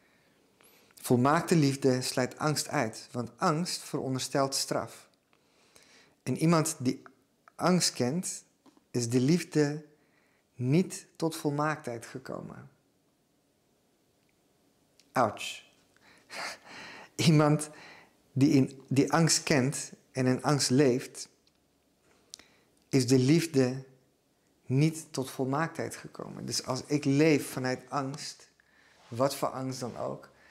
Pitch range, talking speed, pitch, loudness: 130-155 Hz, 100 wpm, 140 Hz, -29 LUFS